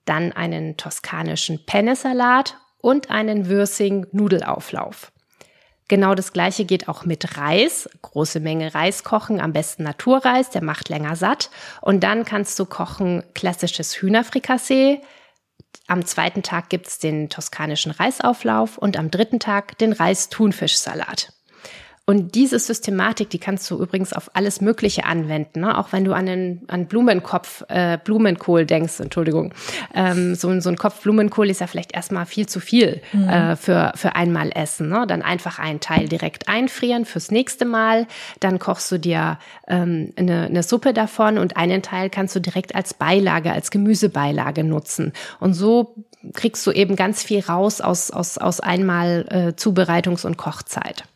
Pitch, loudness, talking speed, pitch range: 190 Hz, -20 LUFS, 155 wpm, 170-215 Hz